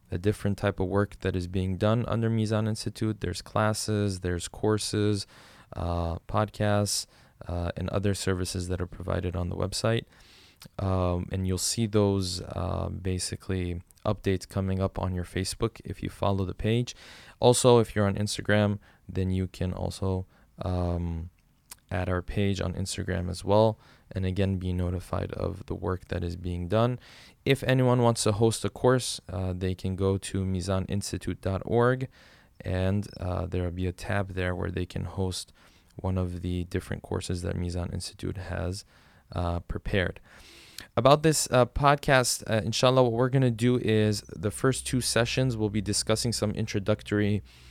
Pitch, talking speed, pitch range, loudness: 100 Hz, 165 wpm, 90-110 Hz, -28 LUFS